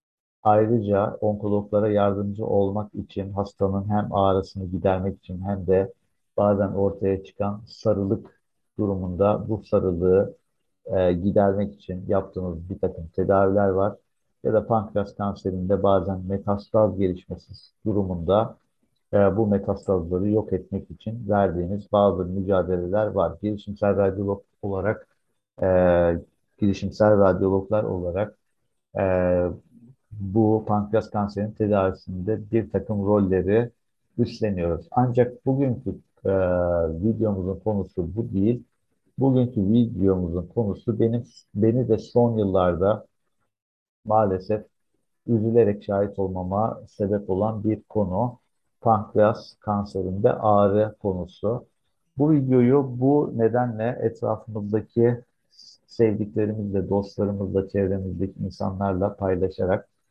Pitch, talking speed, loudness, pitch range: 100 Hz, 100 wpm, -24 LUFS, 95-110 Hz